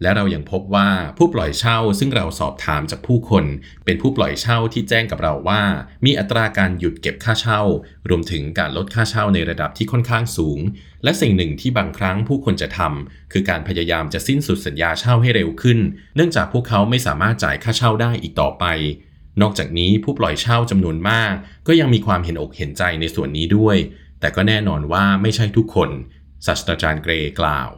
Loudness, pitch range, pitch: -18 LUFS, 80-115 Hz, 100 Hz